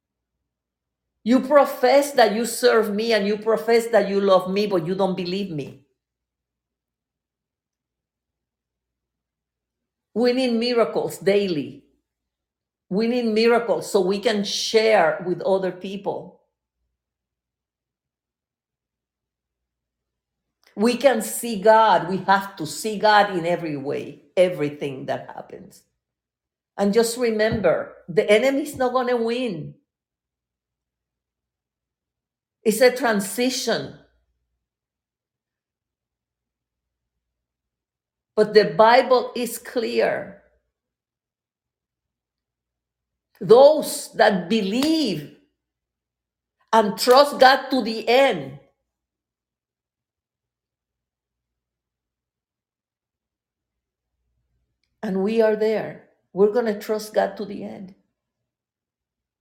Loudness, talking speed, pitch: -20 LUFS, 85 wpm, 205 Hz